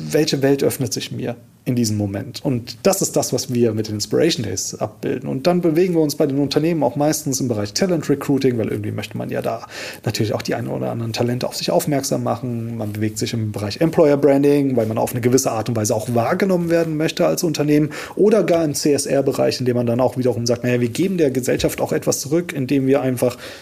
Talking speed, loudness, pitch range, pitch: 235 wpm, -19 LUFS, 120-155 Hz, 135 Hz